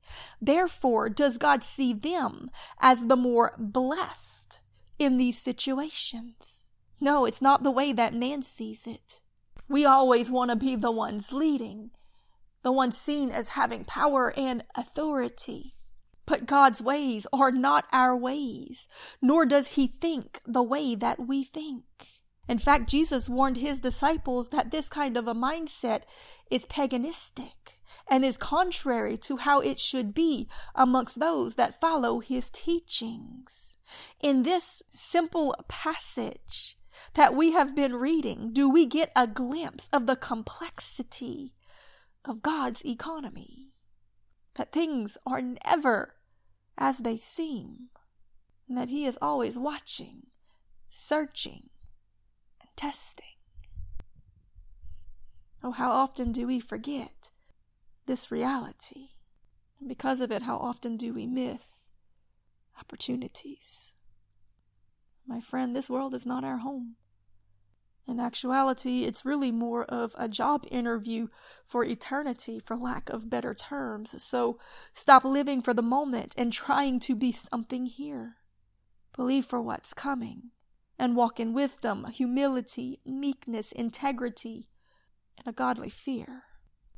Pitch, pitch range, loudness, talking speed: 255 Hz, 230-275 Hz, -28 LUFS, 130 wpm